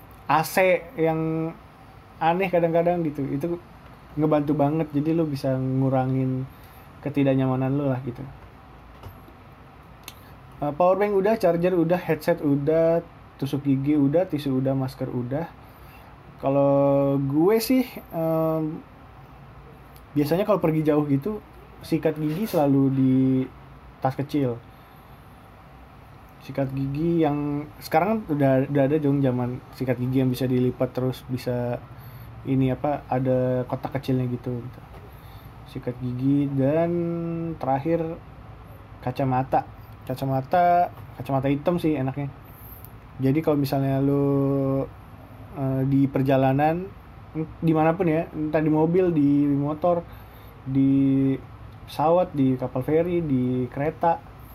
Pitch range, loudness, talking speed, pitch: 130-160 Hz, -24 LUFS, 110 wpm, 135 Hz